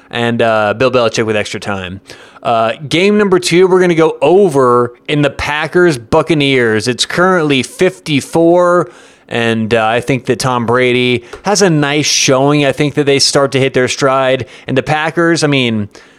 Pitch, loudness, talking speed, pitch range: 135 Hz, -11 LUFS, 180 wpm, 120-160 Hz